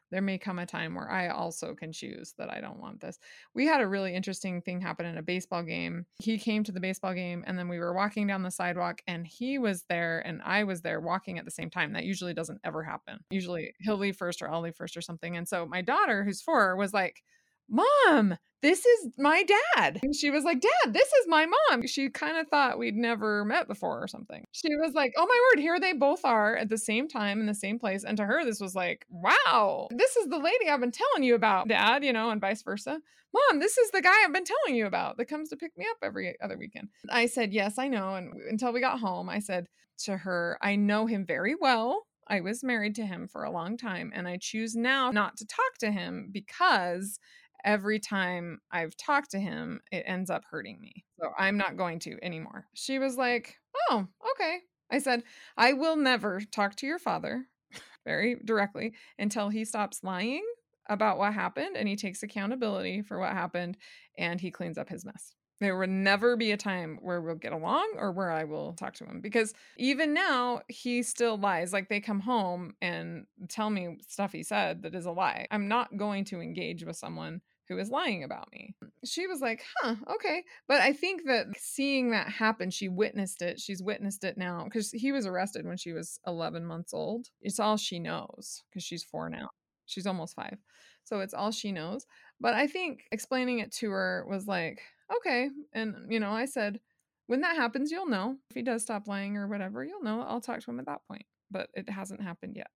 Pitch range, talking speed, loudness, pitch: 190-250 Hz, 225 wpm, -30 LUFS, 215 Hz